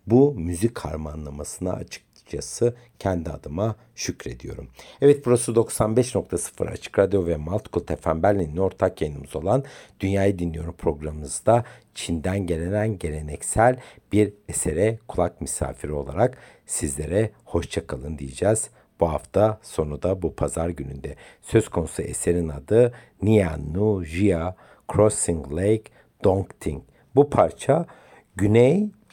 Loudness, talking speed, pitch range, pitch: -24 LUFS, 110 wpm, 80-110 Hz, 95 Hz